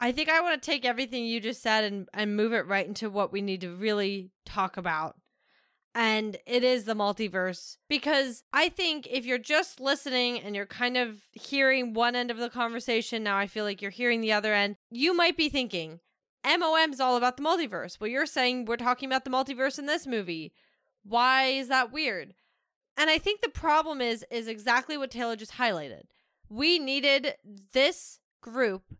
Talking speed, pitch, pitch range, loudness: 195 wpm, 245 Hz, 210-275 Hz, -28 LUFS